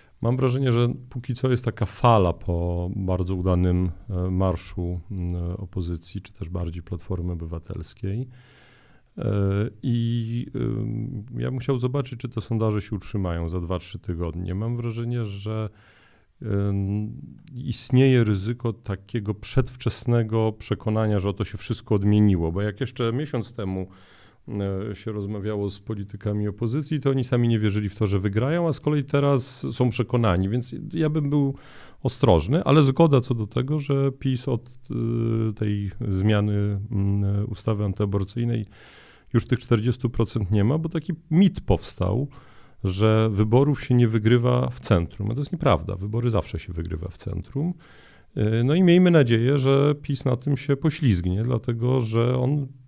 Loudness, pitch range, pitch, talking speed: -24 LUFS, 100-125 Hz, 110 Hz, 145 wpm